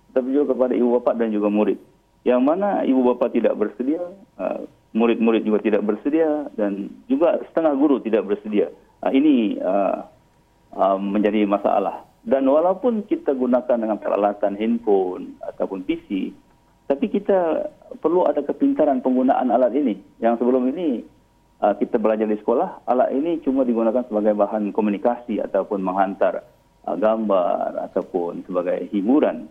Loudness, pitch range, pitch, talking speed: -21 LUFS, 105-175 Hz, 125 Hz, 130 wpm